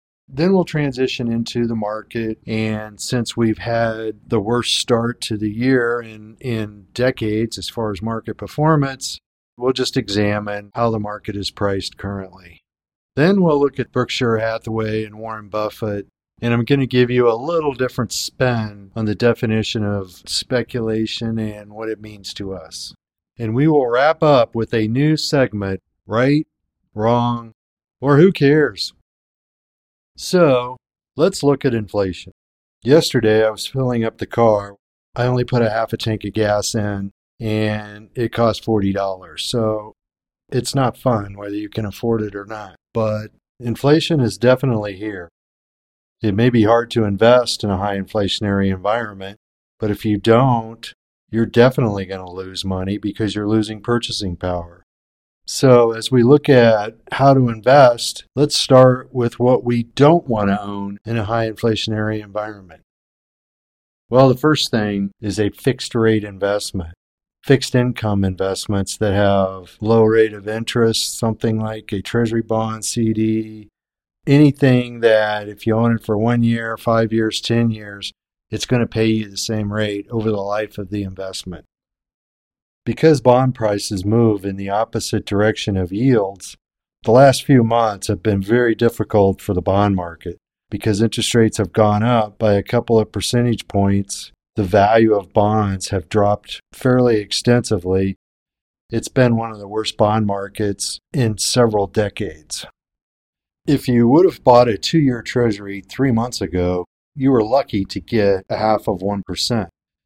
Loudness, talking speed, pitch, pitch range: -18 LUFS, 160 wpm, 110 Hz, 100-120 Hz